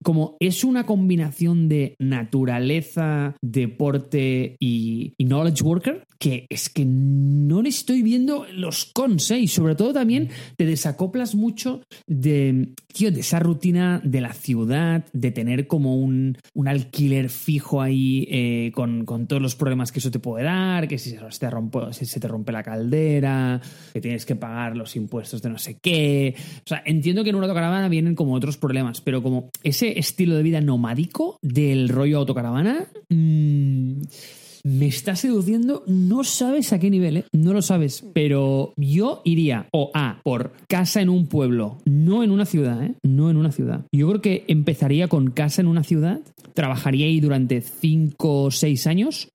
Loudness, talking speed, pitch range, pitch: -21 LUFS, 180 wpm, 130-175 Hz, 150 Hz